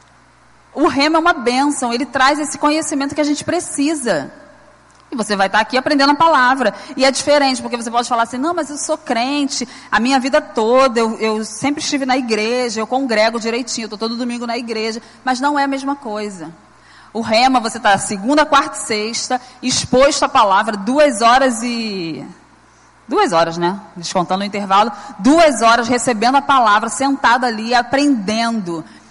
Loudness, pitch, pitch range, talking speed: -16 LUFS, 250 Hz, 220-280 Hz, 180 wpm